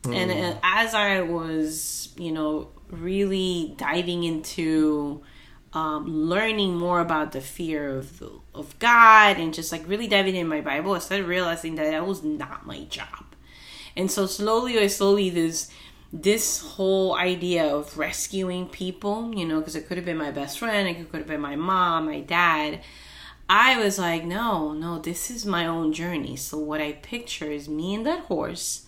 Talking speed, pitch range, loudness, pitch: 175 wpm, 155-195 Hz, -24 LUFS, 170 Hz